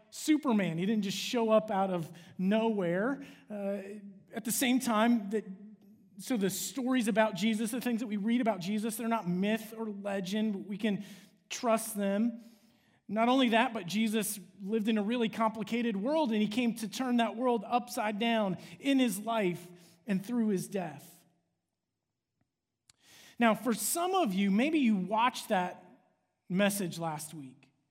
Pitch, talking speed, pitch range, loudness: 215 Hz, 165 wpm, 195-230 Hz, -31 LUFS